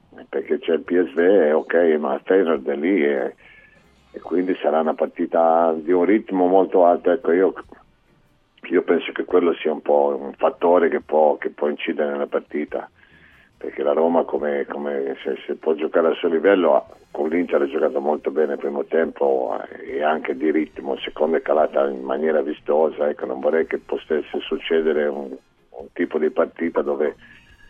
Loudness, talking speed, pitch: -21 LUFS, 175 wpm, 80 Hz